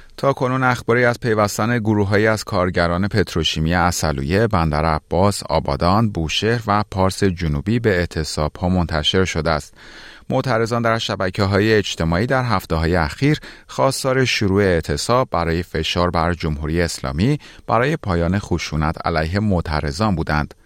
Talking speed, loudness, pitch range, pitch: 130 wpm, -19 LUFS, 80-110 Hz, 90 Hz